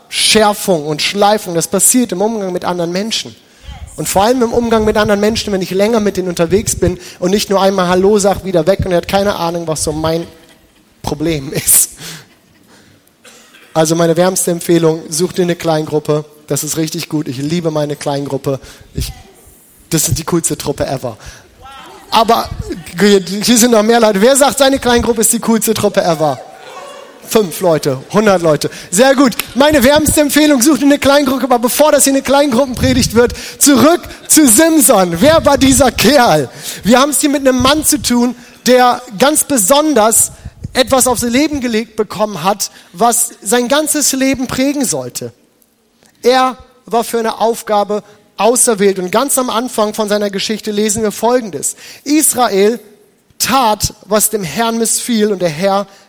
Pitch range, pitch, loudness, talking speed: 175-250 Hz, 215 Hz, -12 LUFS, 170 wpm